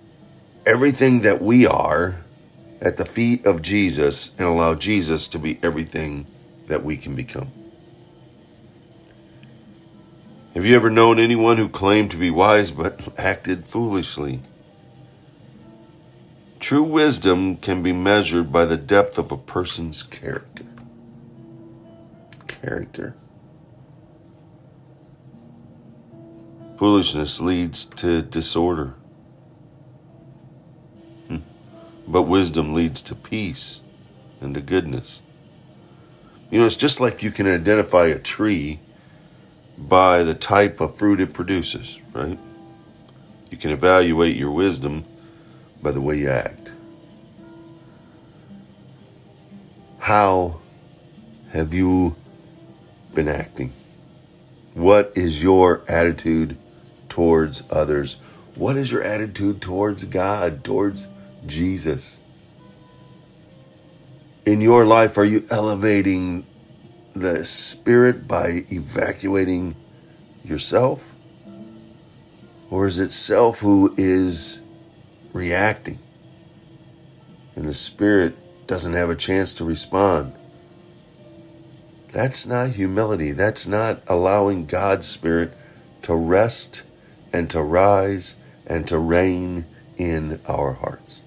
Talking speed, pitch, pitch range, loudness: 100 wpm, 95 Hz, 85-110 Hz, -19 LUFS